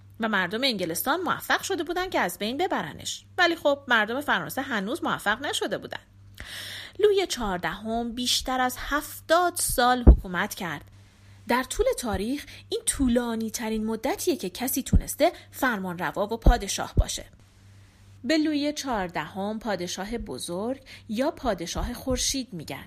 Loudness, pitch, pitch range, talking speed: -26 LUFS, 230 Hz, 180-280 Hz, 130 wpm